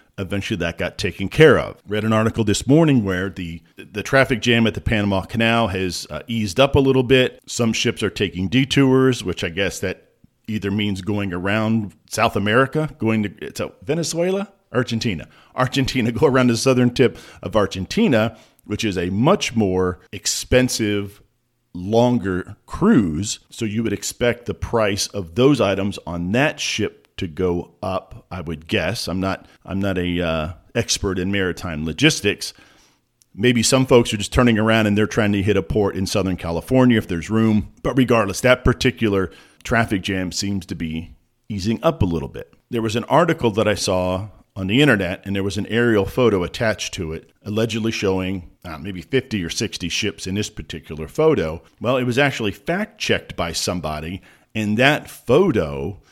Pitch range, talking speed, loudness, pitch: 95-120 Hz, 180 wpm, -20 LUFS, 105 Hz